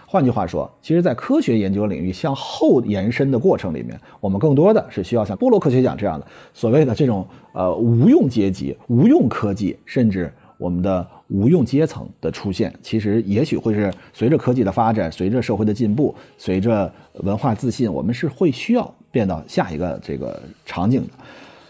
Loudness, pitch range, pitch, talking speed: -19 LUFS, 100-135 Hz, 115 Hz, 295 characters per minute